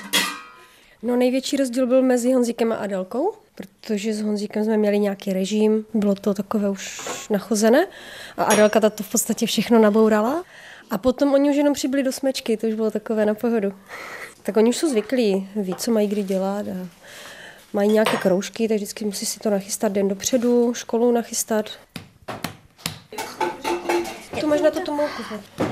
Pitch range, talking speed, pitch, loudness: 210-245 Hz, 165 wpm, 220 Hz, -21 LUFS